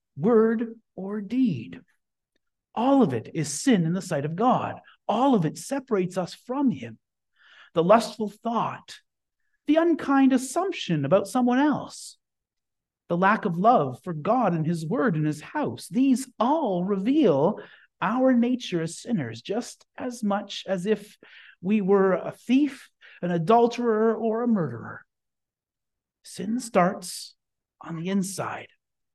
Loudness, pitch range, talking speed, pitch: -25 LUFS, 180-250 Hz, 140 wpm, 215 Hz